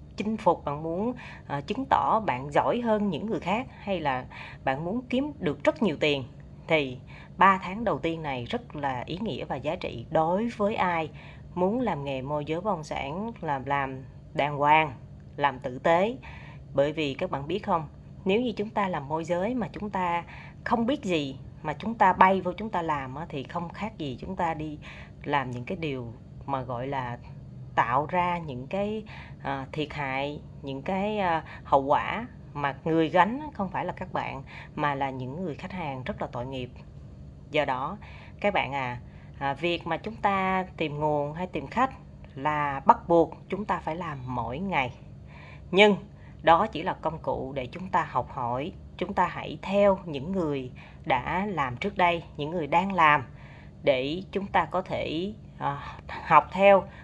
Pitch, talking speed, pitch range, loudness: 160 Hz, 185 wpm, 140-190 Hz, -28 LUFS